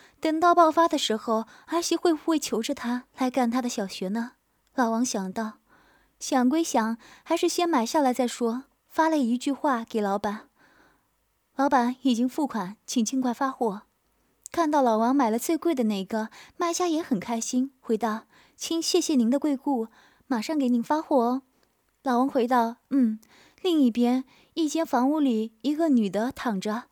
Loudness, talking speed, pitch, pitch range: -26 LUFS, 240 characters per minute, 255 Hz, 230-300 Hz